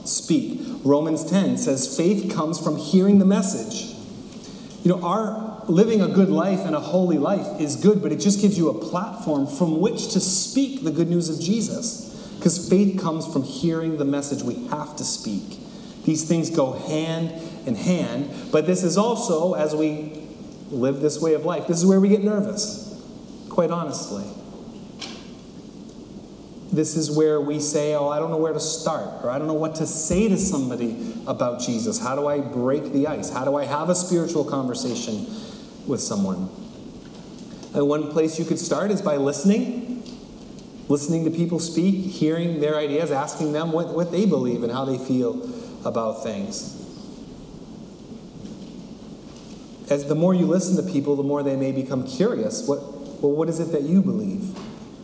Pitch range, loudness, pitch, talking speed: 155-215 Hz, -22 LUFS, 175 Hz, 175 wpm